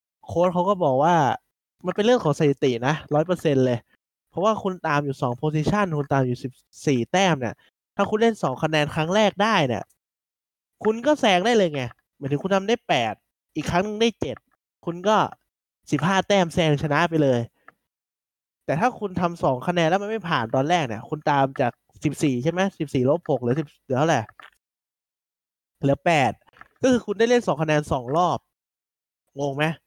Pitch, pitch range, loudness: 160 Hz, 140-195 Hz, -23 LUFS